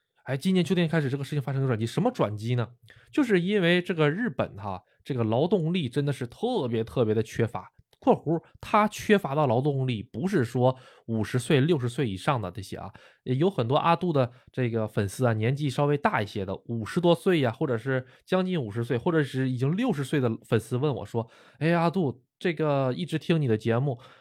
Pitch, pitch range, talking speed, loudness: 130 Hz, 115-165 Hz, 320 characters per minute, -27 LUFS